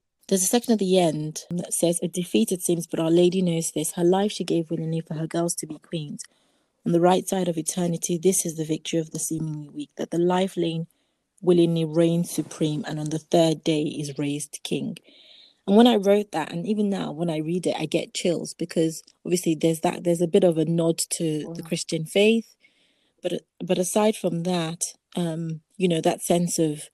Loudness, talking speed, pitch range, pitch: -24 LUFS, 215 wpm, 160-185 Hz, 170 Hz